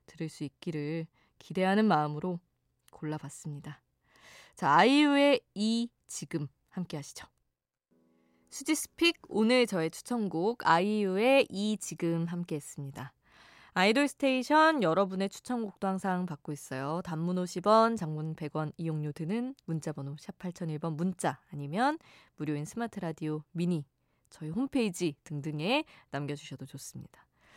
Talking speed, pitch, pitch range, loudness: 285 characters per minute, 170 Hz, 150-215 Hz, -31 LUFS